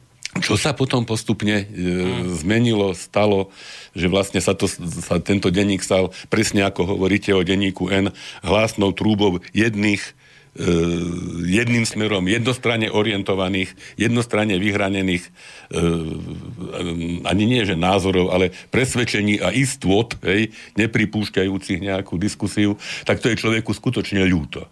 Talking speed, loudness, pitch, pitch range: 120 wpm, -20 LUFS, 100 Hz, 90-105 Hz